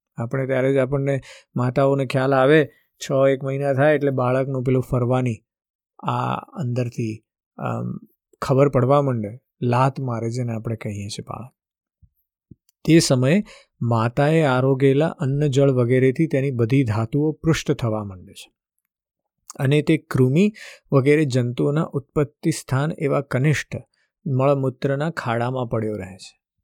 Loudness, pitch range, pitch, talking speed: -21 LUFS, 125-145 Hz, 135 Hz, 125 wpm